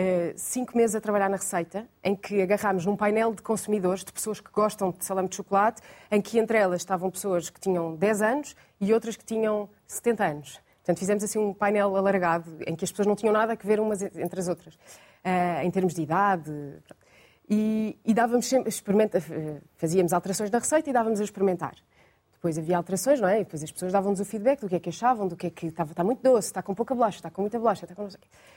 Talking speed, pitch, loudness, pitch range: 235 wpm, 200 Hz, -26 LUFS, 180-215 Hz